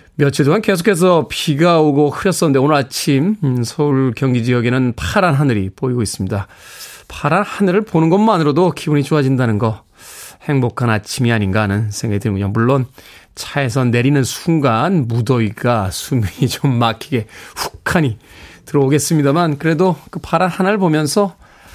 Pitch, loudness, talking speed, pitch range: 140 Hz, -15 LUFS, 335 characters per minute, 120-160 Hz